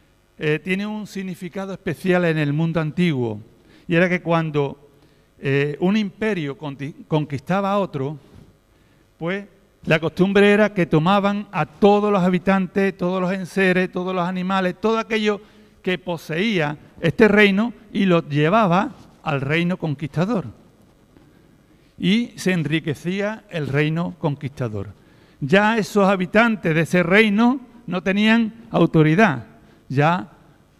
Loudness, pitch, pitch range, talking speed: -20 LUFS, 180 Hz, 155-200 Hz, 125 wpm